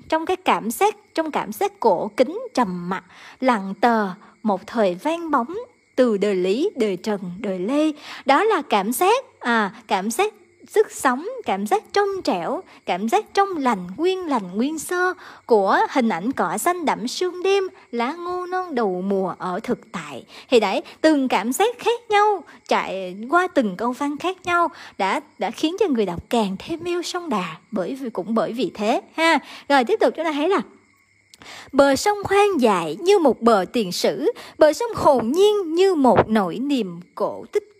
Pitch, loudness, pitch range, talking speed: 280 Hz, -21 LUFS, 220-370 Hz, 190 wpm